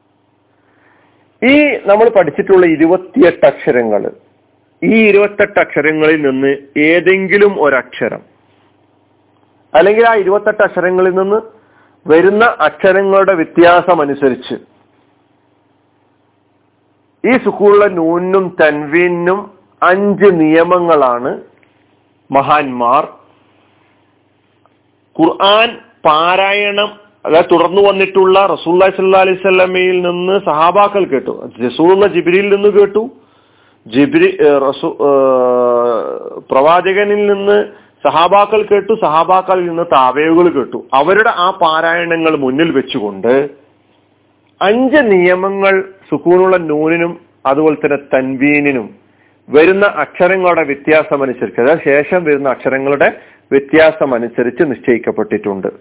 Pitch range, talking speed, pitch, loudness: 145-200 Hz, 75 wpm, 175 Hz, -11 LUFS